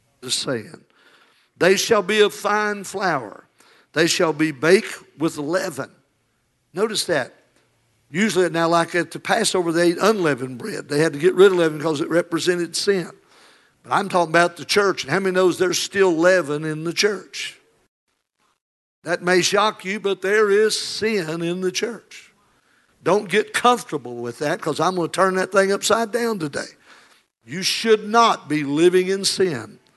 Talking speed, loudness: 170 wpm, -20 LUFS